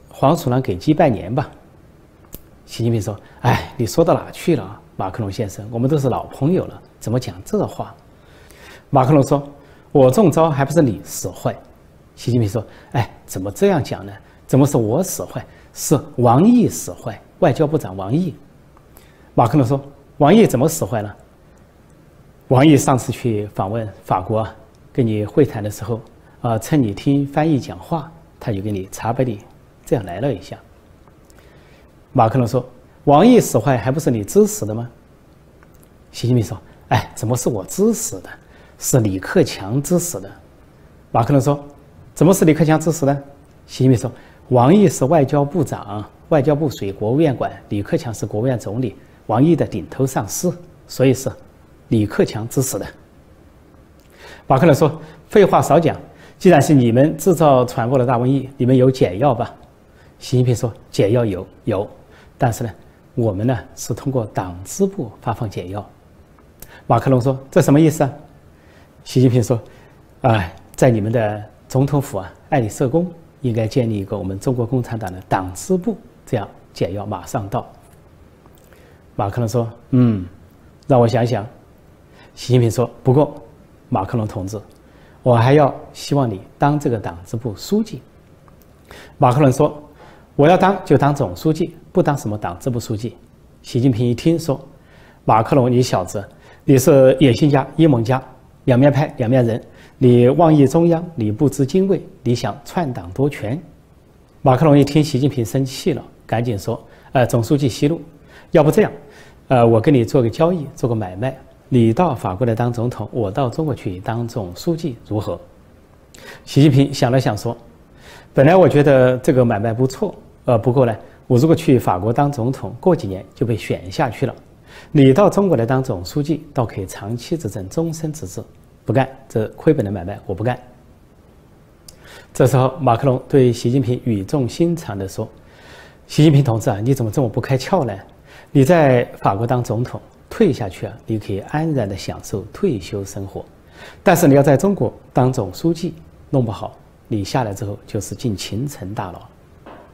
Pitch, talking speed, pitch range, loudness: 125 Hz, 250 characters per minute, 110-145 Hz, -17 LUFS